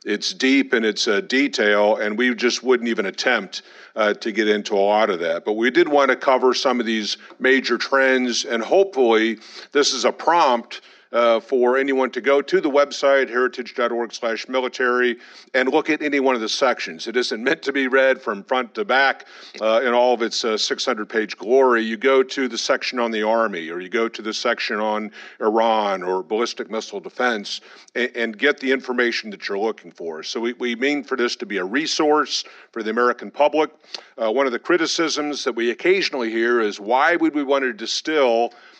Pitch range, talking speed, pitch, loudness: 115-140 Hz, 210 wpm, 125 Hz, -20 LUFS